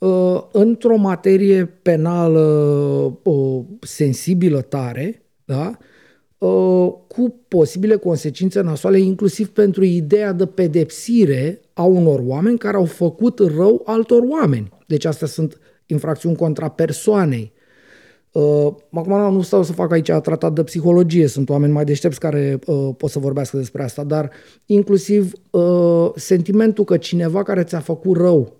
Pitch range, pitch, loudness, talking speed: 150-195 Hz, 170 Hz, -17 LUFS, 135 wpm